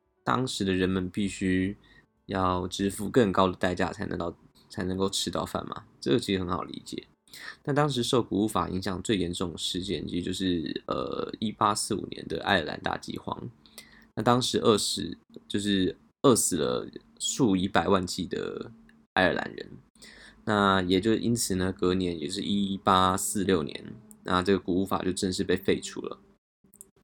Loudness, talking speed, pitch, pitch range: -28 LUFS, 250 characters per minute, 95 Hz, 90-100 Hz